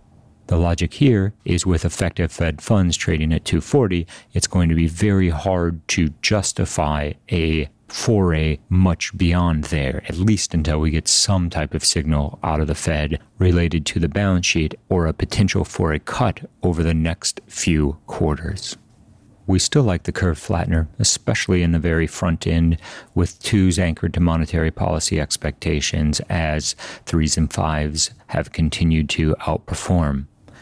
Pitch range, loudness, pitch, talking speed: 80-95 Hz, -20 LUFS, 85 Hz, 155 wpm